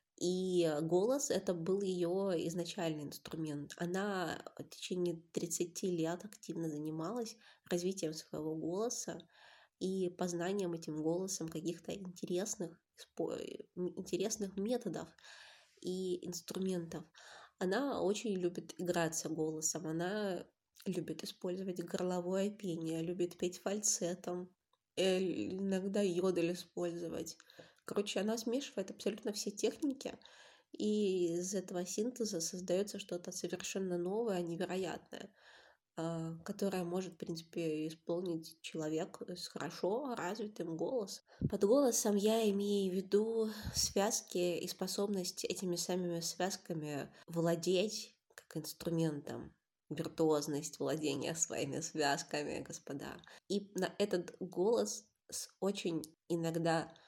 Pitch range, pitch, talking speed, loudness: 170-200 Hz, 180 Hz, 100 wpm, -38 LUFS